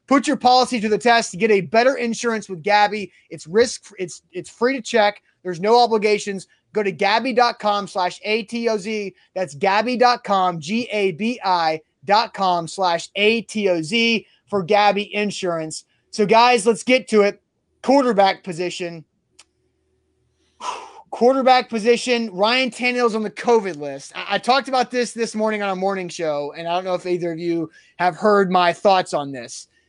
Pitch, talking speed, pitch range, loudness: 205 Hz, 155 wpm, 180-235 Hz, -19 LUFS